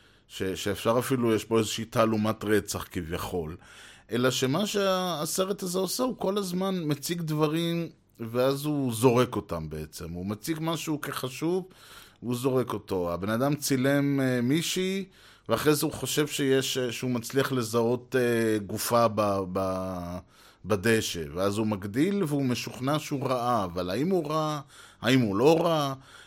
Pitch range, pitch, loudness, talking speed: 105-150 Hz, 125 Hz, -28 LUFS, 140 wpm